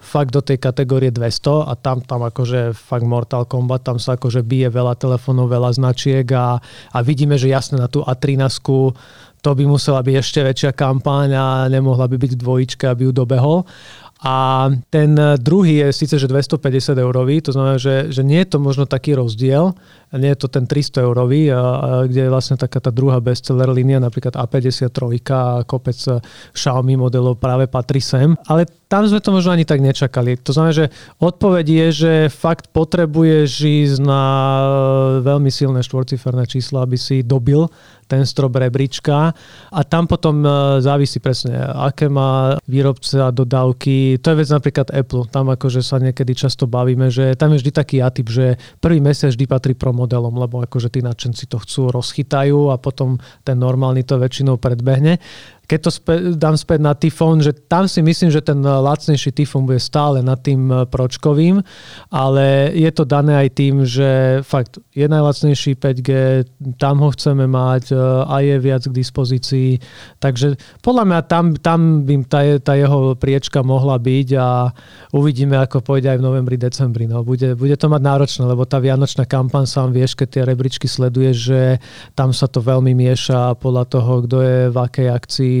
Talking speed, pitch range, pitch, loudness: 175 wpm, 130-145 Hz, 135 Hz, -15 LUFS